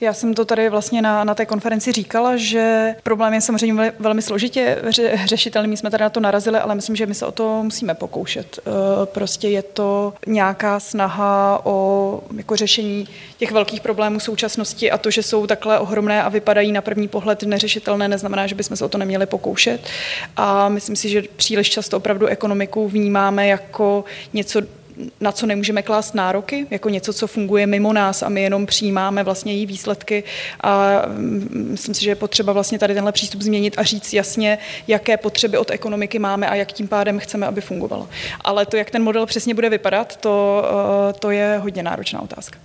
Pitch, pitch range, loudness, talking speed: 210 Hz, 200-220 Hz, -18 LUFS, 190 wpm